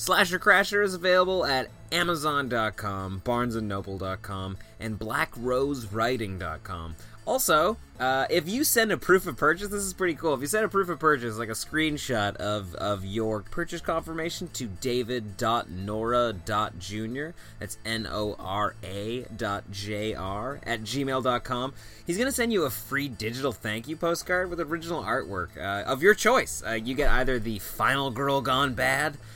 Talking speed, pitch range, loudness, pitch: 145 wpm, 105-160 Hz, -27 LUFS, 125 Hz